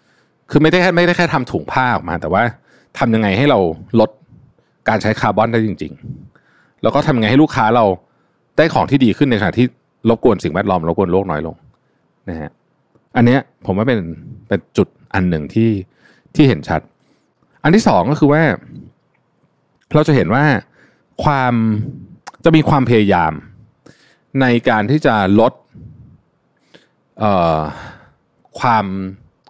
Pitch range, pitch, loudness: 95-135 Hz, 115 Hz, -15 LUFS